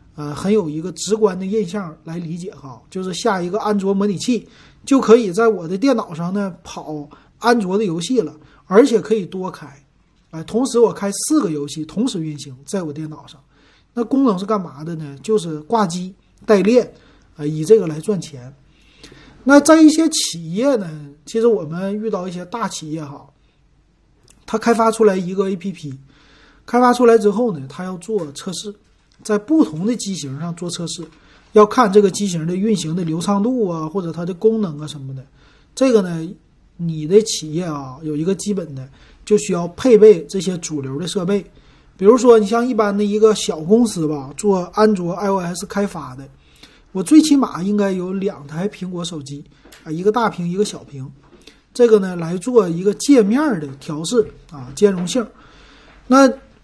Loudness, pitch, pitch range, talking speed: -17 LUFS, 190 Hz, 155-220 Hz, 265 characters per minute